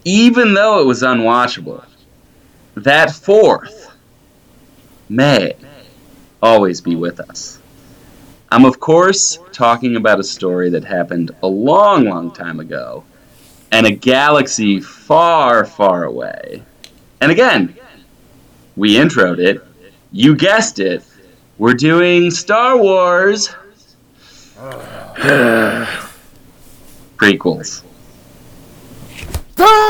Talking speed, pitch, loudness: 90 wpm, 130 Hz, -12 LUFS